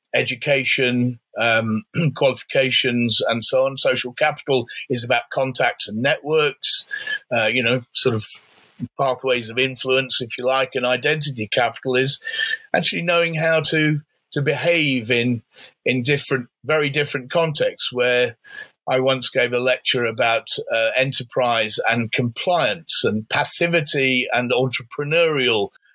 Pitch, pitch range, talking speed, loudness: 130 Hz, 125-155 Hz, 125 wpm, -20 LUFS